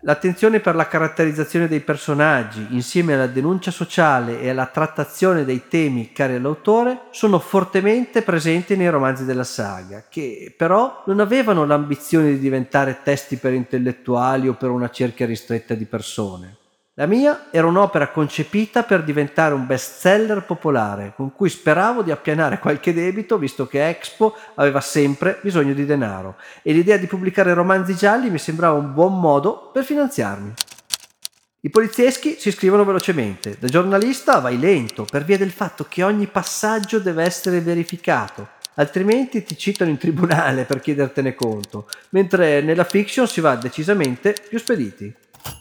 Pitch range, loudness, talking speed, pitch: 135-195 Hz, -19 LUFS, 150 wpm, 160 Hz